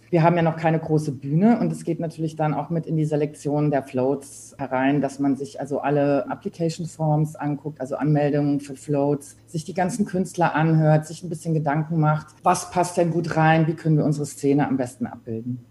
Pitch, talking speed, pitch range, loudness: 150 Hz, 210 wpm, 140-165 Hz, -23 LUFS